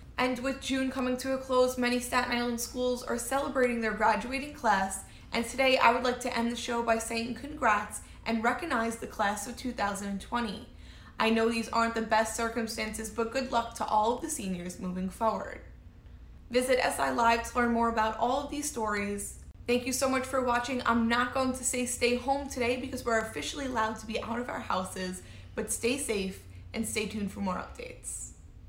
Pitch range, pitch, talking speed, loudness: 220-255 Hz, 235 Hz, 200 wpm, -30 LUFS